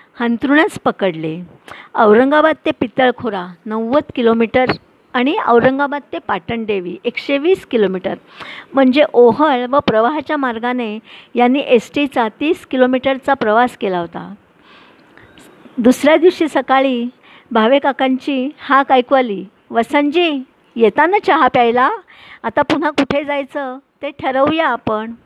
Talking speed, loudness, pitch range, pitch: 105 wpm, -15 LUFS, 230-285 Hz, 255 Hz